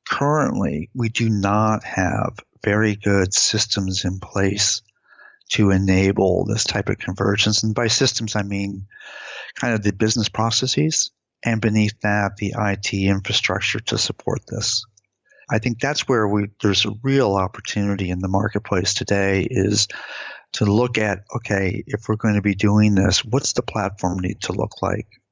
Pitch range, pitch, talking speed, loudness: 100-110 Hz, 105 Hz, 160 wpm, -20 LUFS